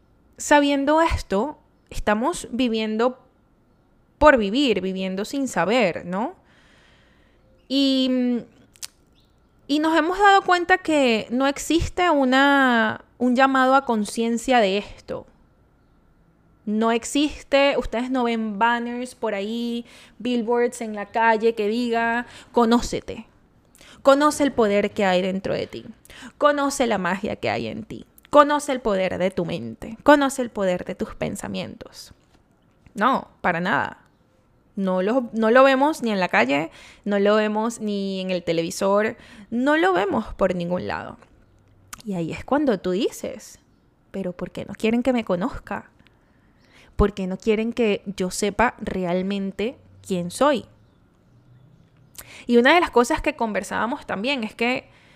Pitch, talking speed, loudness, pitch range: 230 Hz, 140 wpm, -21 LUFS, 200-270 Hz